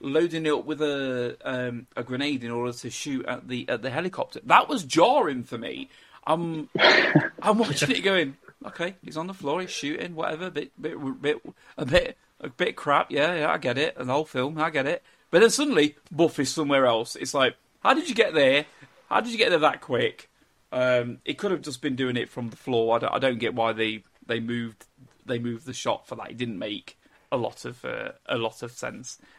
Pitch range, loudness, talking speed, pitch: 120-160 Hz, -25 LUFS, 230 wpm, 135 Hz